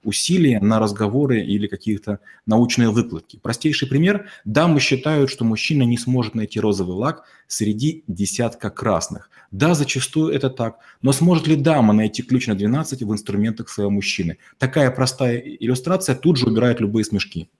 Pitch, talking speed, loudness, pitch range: 120 Hz, 155 wpm, -19 LUFS, 105-140 Hz